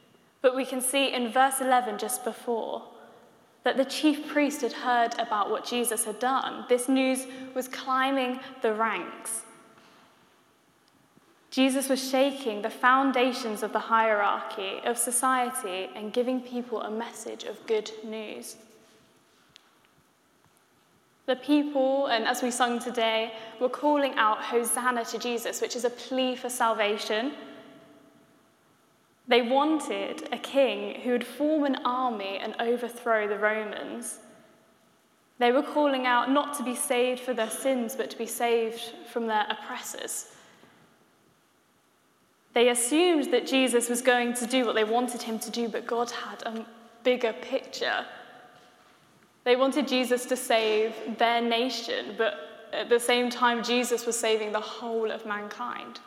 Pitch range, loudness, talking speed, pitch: 225-260 Hz, -27 LUFS, 140 wpm, 245 Hz